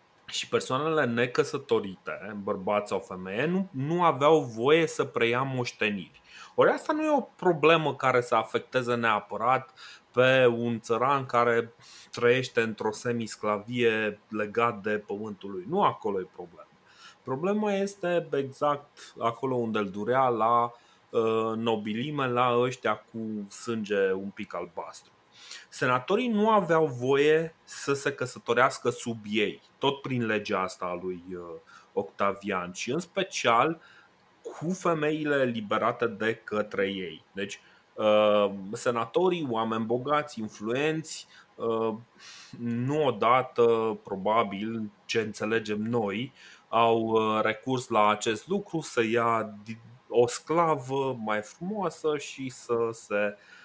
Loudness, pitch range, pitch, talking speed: -28 LUFS, 110-145 Hz, 120 Hz, 115 wpm